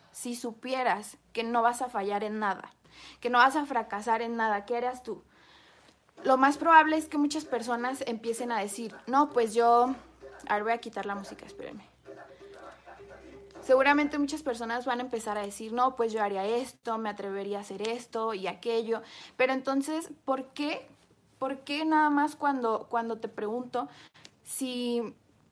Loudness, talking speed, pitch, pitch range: -29 LUFS, 170 wpm, 240 Hz, 225-265 Hz